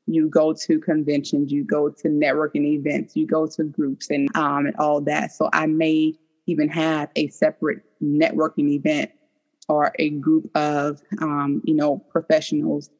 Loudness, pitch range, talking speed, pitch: -22 LUFS, 150-240 Hz, 160 wpm, 155 Hz